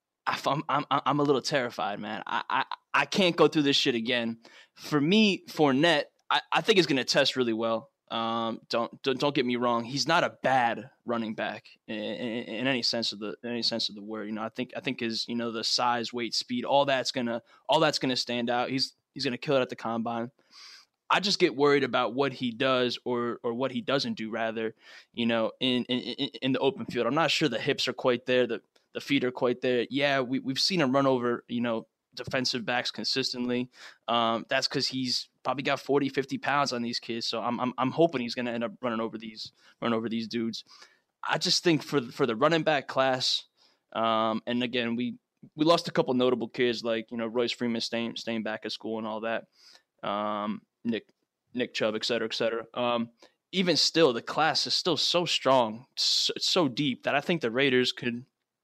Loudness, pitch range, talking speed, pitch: -28 LUFS, 115-135 Hz, 225 wpm, 125 Hz